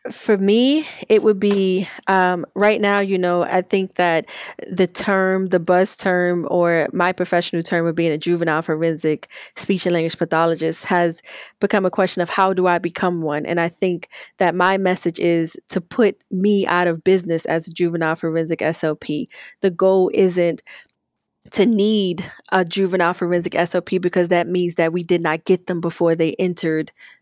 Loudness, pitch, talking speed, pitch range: -19 LUFS, 180 Hz, 175 wpm, 170-190 Hz